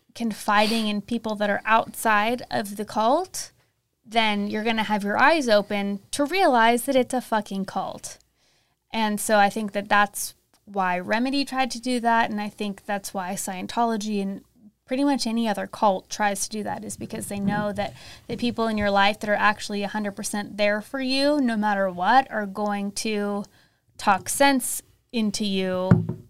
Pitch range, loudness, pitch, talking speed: 205-230 Hz, -24 LUFS, 215 Hz, 180 wpm